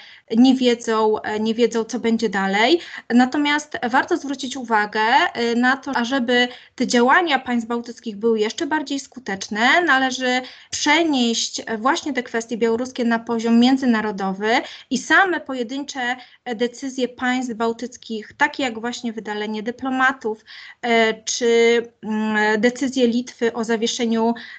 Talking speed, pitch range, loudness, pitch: 115 wpm, 230-260 Hz, -20 LUFS, 240 Hz